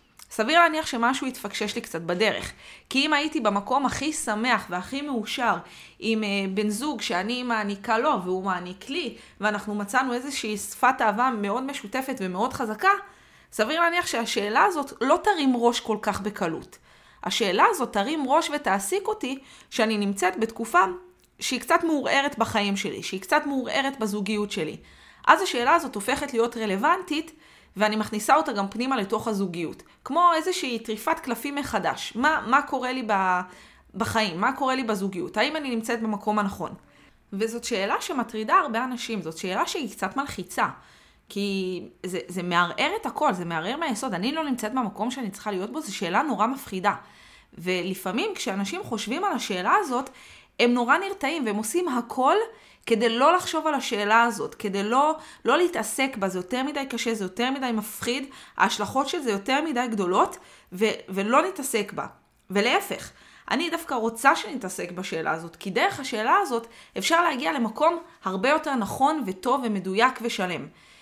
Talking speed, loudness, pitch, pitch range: 155 wpm, -25 LUFS, 235 Hz, 205-275 Hz